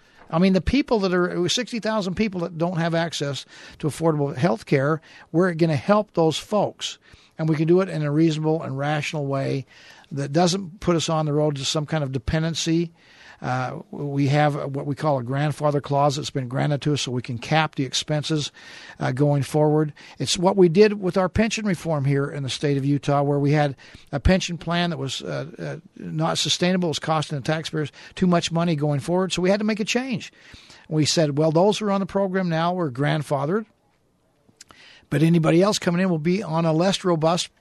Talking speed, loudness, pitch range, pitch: 215 wpm, -22 LUFS, 145-180 Hz, 160 Hz